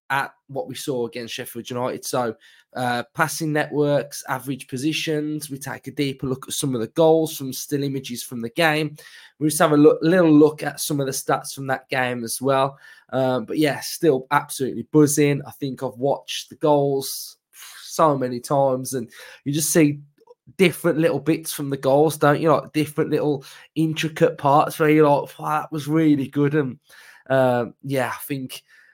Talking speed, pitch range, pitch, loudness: 190 wpm, 130-155 Hz, 145 Hz, -21 LUFS